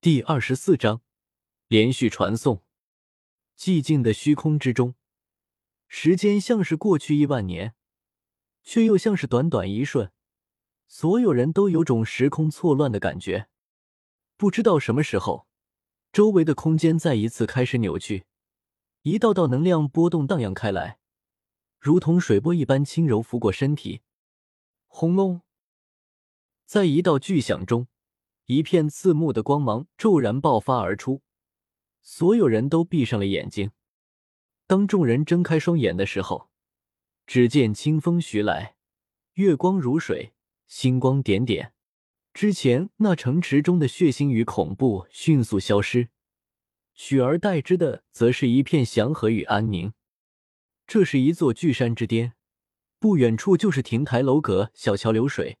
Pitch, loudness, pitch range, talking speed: 130 Hz, -22 LUFS, 110-165 Hz, 210 characters per minute